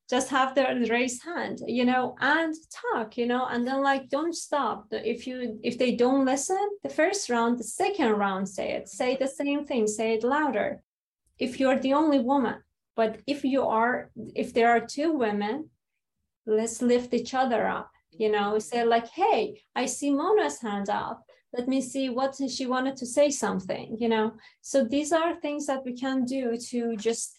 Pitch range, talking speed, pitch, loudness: 230-280 Hz, 190 wpm, 255 Hz, -27 LUFS